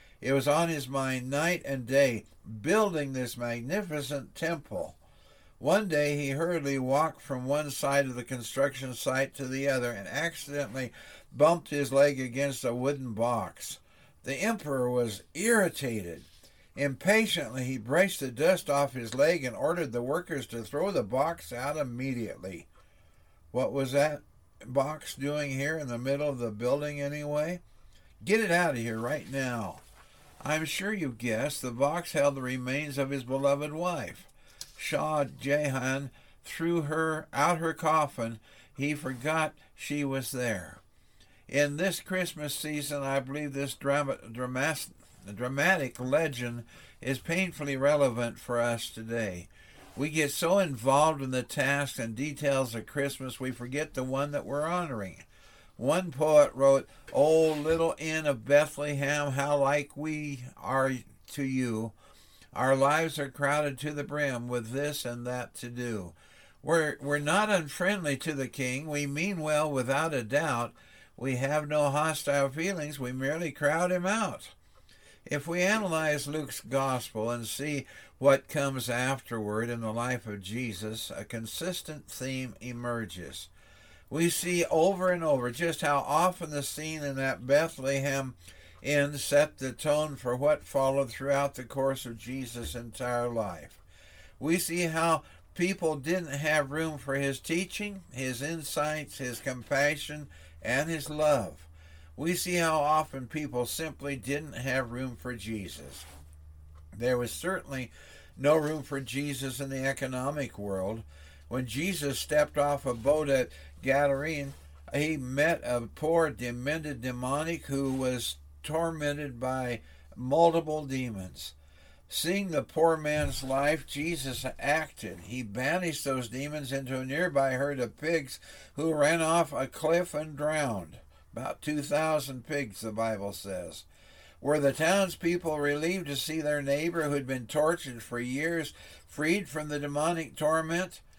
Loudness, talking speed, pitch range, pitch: -30 LUFS, 145 wpm, 125-150 Hz, 140 Hz